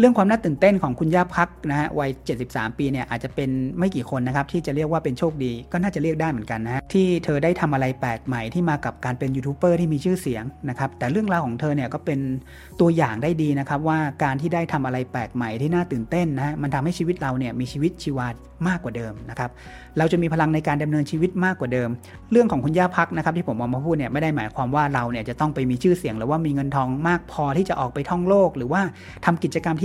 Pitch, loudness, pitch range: 150 Hz, -23 LUFS, 130-170 Hz